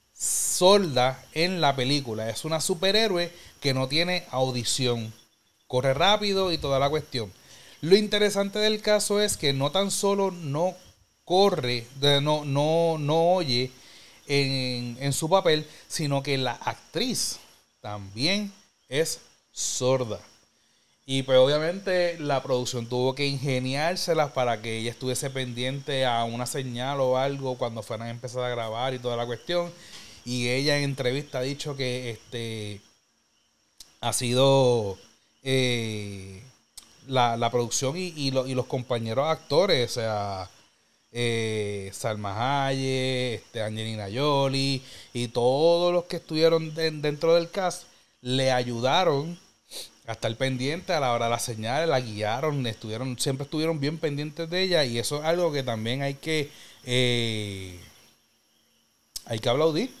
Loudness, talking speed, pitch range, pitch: -26 LUFS, 140 wpm, 120-160 Hz, 130 Hz